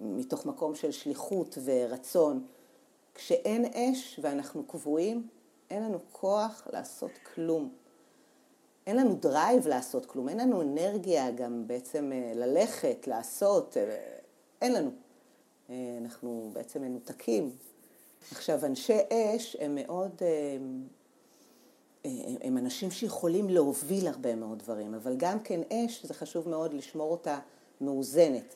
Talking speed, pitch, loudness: 115 wpm, 175 Hz, -32 LUFS